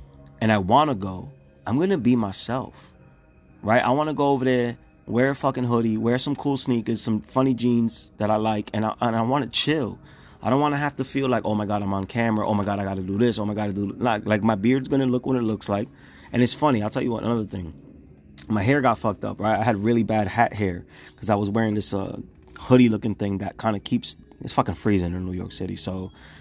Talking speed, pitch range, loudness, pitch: 260 wpm, 100-125 Hz, -23 LUFS, 110 Hz